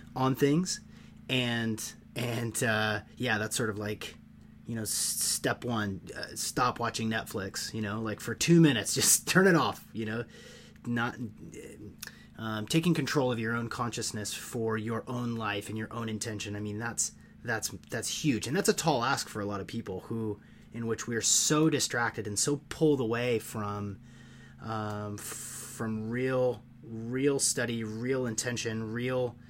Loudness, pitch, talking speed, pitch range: -30 LUFS, 115 Hz, 165 wpm, 105-125 Hz